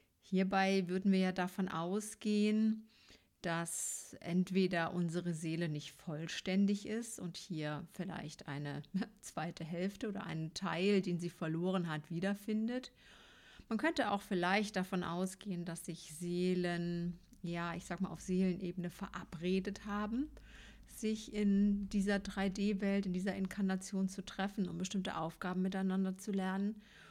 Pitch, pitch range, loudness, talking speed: 190 Hz, 175-200 Hz, -38 LUFS, 130 wpm